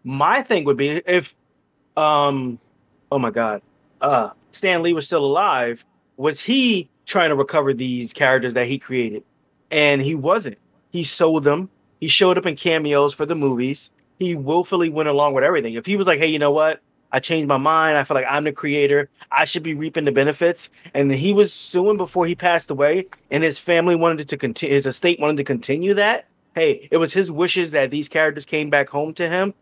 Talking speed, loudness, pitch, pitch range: 205 wpm, -19 LUFS, 150 Hz, 140-170 Hz